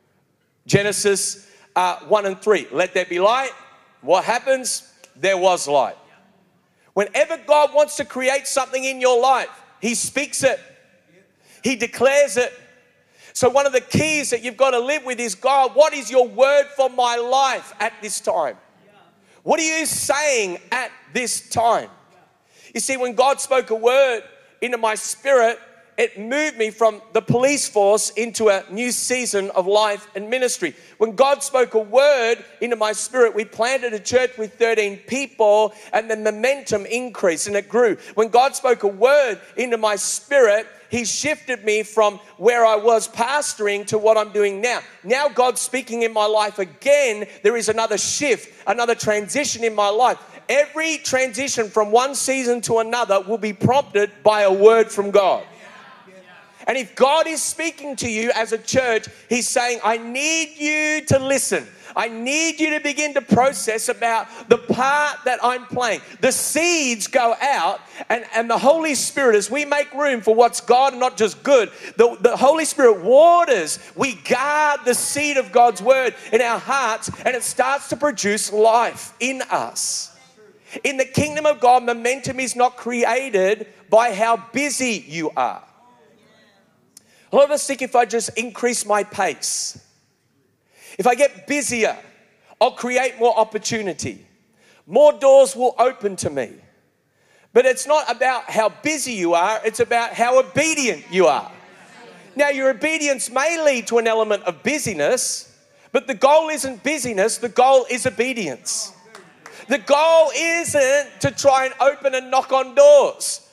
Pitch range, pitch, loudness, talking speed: 215-275 Hz, 245 Hz, -19 LUFS, 165 wpm